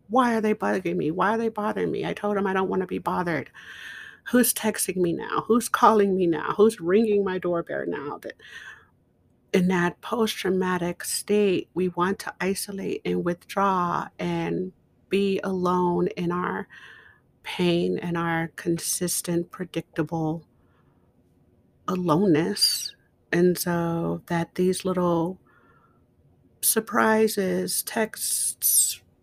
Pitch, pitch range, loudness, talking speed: 185 Hz, 175-205 Hz, -24 LUFS, 125 wpm